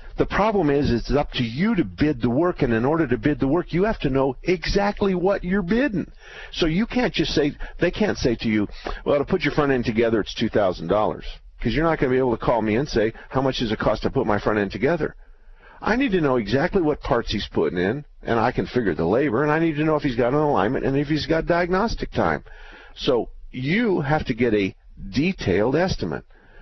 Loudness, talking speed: -22 LUFS, 245 wpm